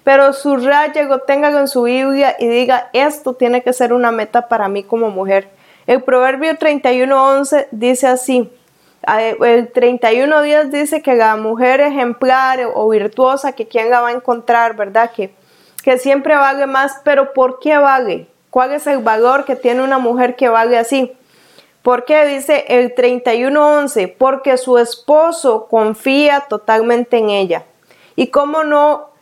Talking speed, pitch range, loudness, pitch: 155 wpm, 235-275 Hz, -13 LUFS, 255 Hz